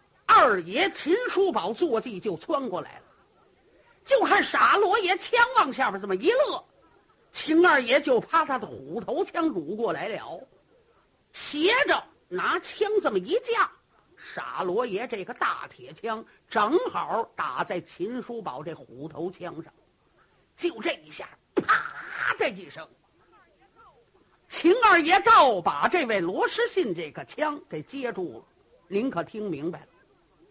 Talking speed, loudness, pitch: 195 characters per minute, -25 LUFS, 350 Hz